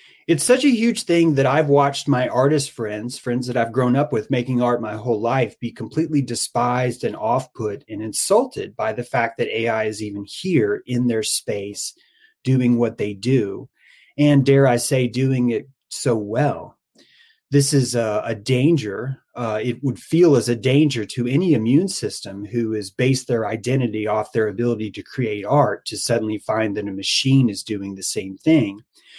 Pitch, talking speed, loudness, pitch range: 125 Hz, 185 wpm, -20 LUFS, 110-145 Hz